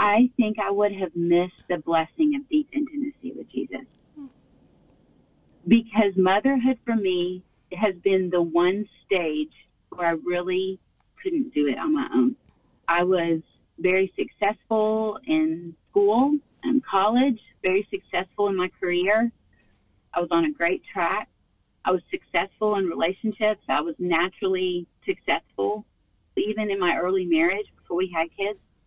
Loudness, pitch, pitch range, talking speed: -24 LUFS, 195 Hz, 175-235 Hz, 140 wpm